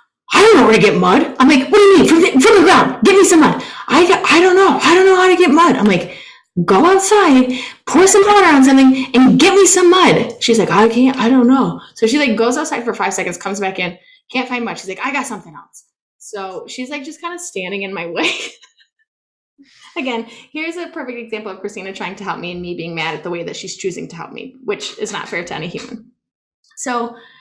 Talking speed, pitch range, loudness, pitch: 255 wpm, 205-340 Hz, -11 LUFS, 255 Hz